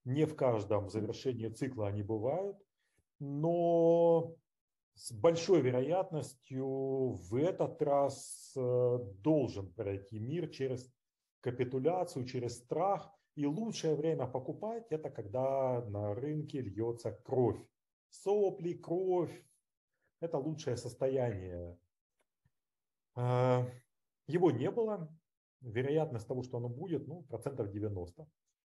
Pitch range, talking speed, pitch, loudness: 120-160 Hz, 100 wpm, 135 Hz, -35 LUFS